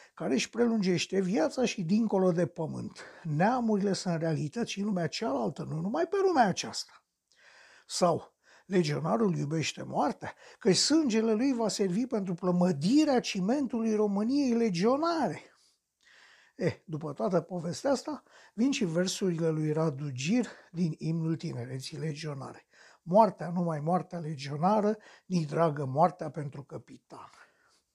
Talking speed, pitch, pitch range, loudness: 130 wpm, 185 Hz, 165-225 Hz, -30 LUFS